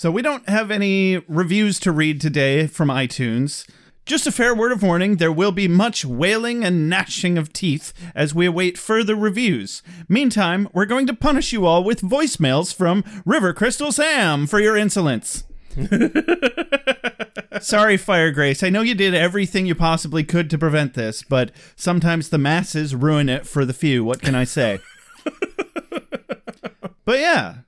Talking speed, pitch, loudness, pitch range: 165 wpm, 180 Hz, -19 LUFS, 155-220 Hz